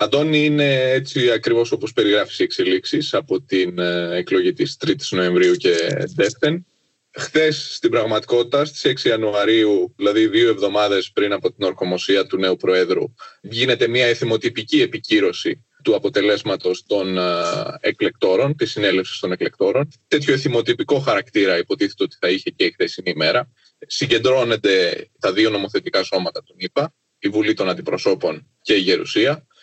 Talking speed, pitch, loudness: 140 wpm, 345 Hz, -19 LUFS